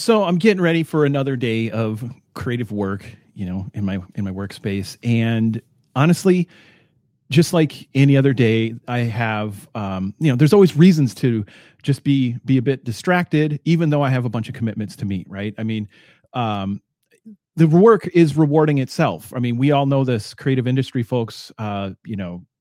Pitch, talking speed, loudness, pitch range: 125 Hz, 185 wpm, -19 LUFS, 110-150 Hz